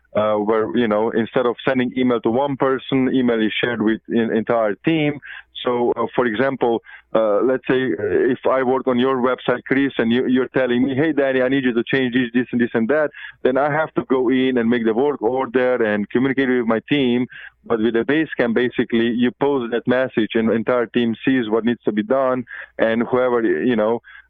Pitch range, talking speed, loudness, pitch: 115-130 Hz, 220 wpm, -19 LUFS, 125 Hz